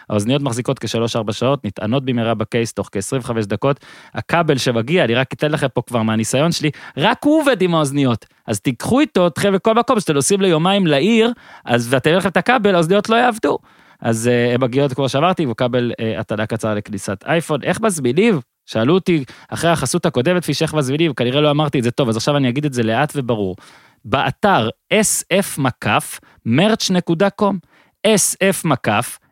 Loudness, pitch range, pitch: -17 LUFS, 120-180 Hz, 140 Hz